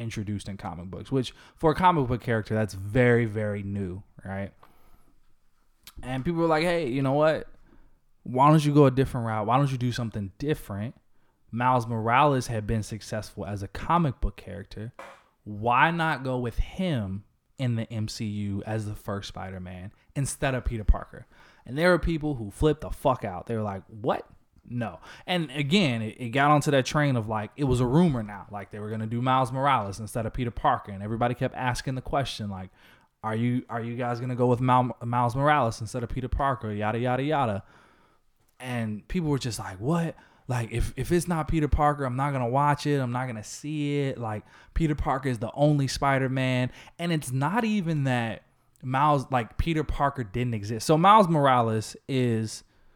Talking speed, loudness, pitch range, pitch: 200 wpm, -27 LUFS, 110-140 Hz, 125 Hz